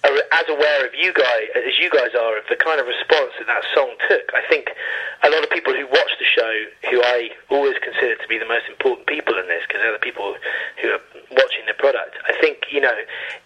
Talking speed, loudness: 240 wpm, -19 LUFS